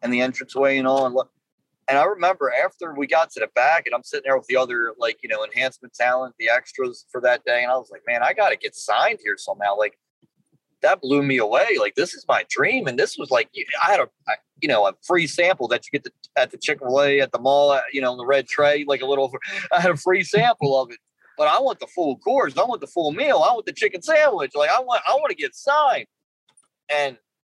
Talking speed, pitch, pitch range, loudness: 255 wpm, 140 Hz, 130-185 Hz, -21 LUFS